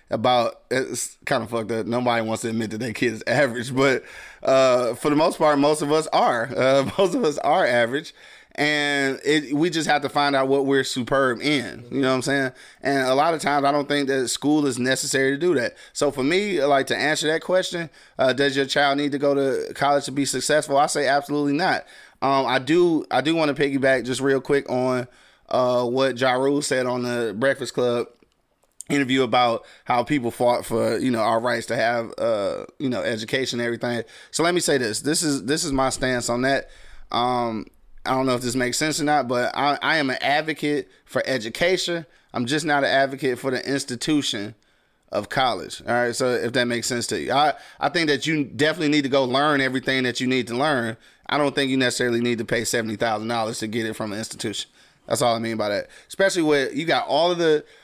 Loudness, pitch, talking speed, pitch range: -22 LUFS, 135 Hz, 230 wpm, 125-145 Hz